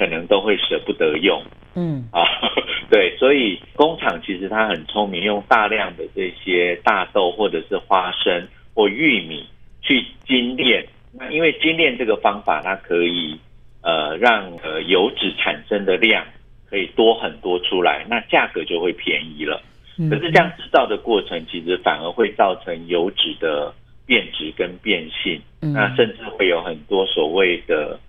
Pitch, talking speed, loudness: 130 Hz, 235 characters per minute, -19 LUFS